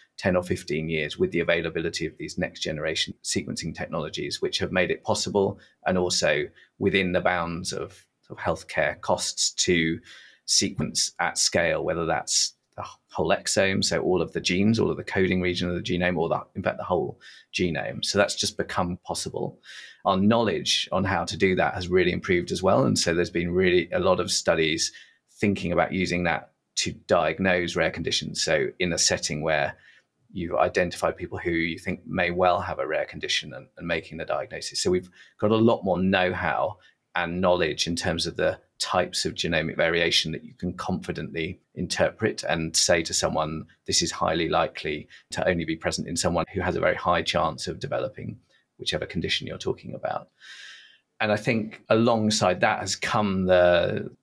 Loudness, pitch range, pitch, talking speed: -25 LUFS, 85-95 Hz, 90 Hz, 190 wpm